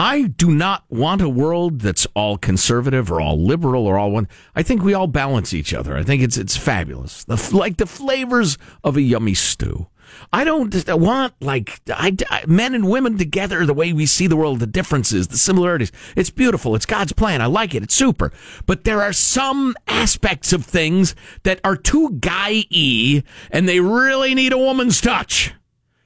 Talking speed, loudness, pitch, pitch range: 195 wpm, -17 LUFS, 165 Hz, 120-200 Hz